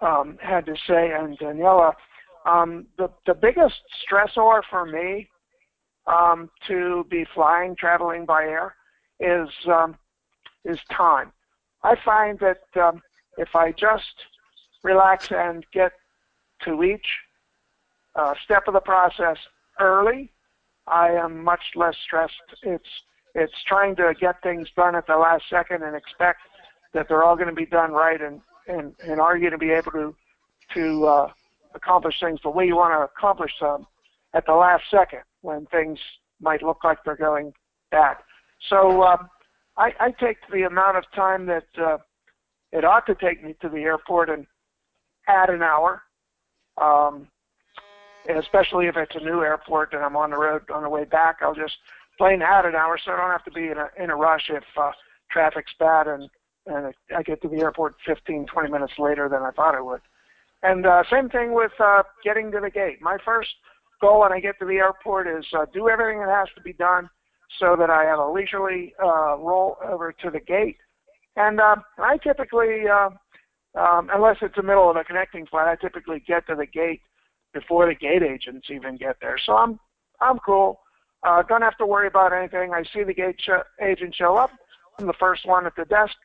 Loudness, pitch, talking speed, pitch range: -21 LUFS, 175 Hz, 185 wpm, 160-195 Hz